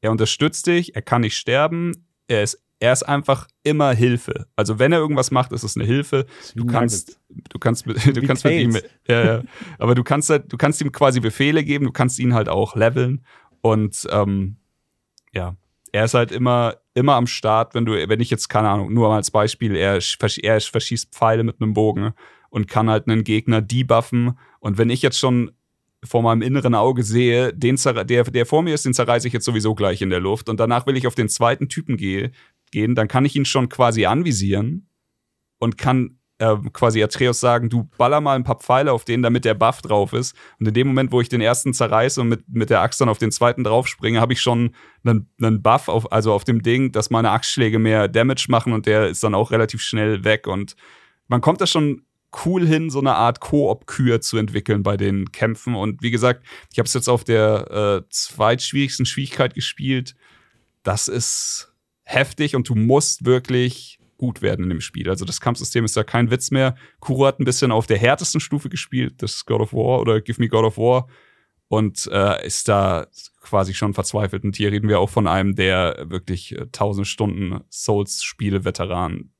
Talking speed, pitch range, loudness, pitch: 210 wpm, 110-130 Hz, -19 LUFS, 120 Hz